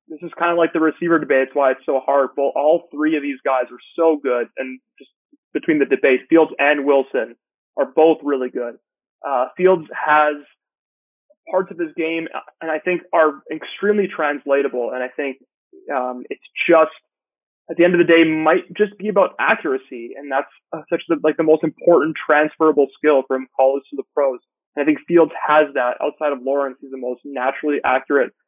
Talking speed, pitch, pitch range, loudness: 200 wpm, 155 Hz, 140-170 Hz, -18 LUFS